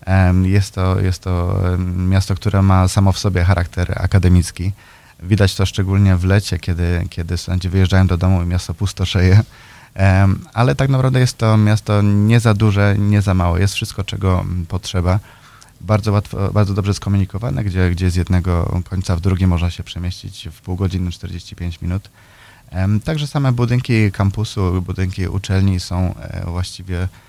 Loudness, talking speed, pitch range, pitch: -17 LUFS, 155 wpm, 90-105 Hz, 95 Hz